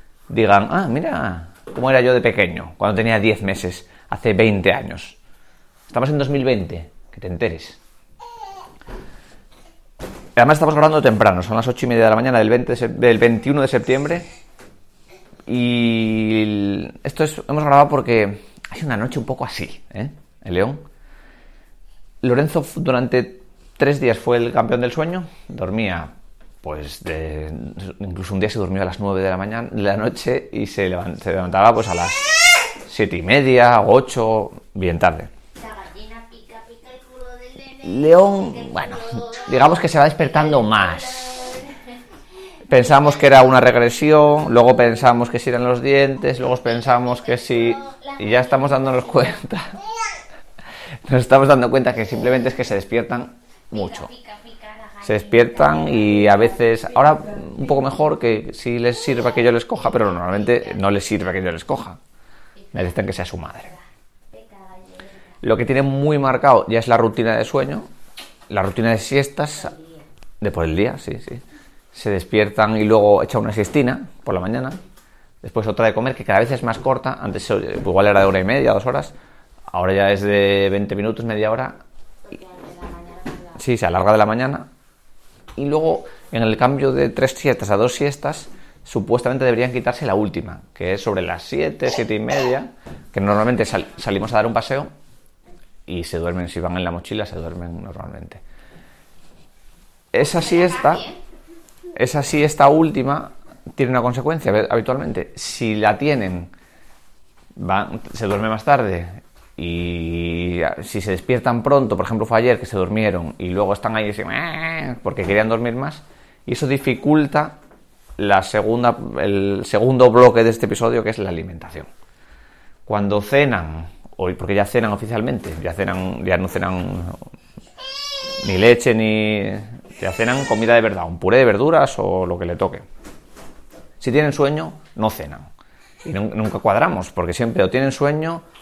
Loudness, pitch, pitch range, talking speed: -17 LUFS, 120 Hz, 100-140 Hz, 160 wpm